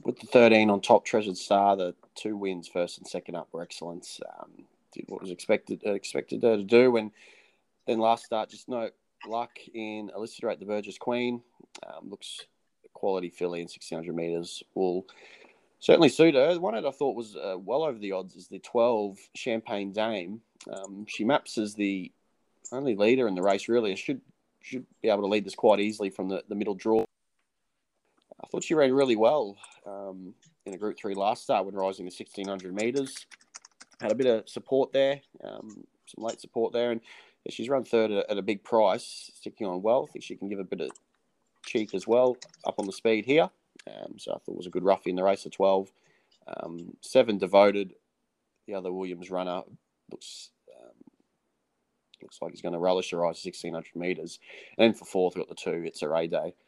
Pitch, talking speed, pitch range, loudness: 100 Hz, 205 wpm, 95-115 Hz, -28 LUFS